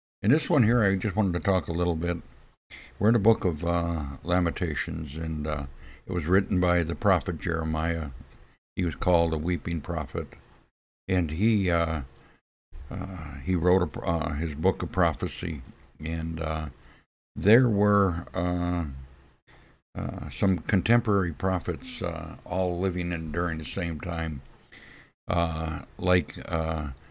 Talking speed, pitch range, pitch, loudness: 145 wpm, 75-90 Hz, 85 Hz, -27 LUFS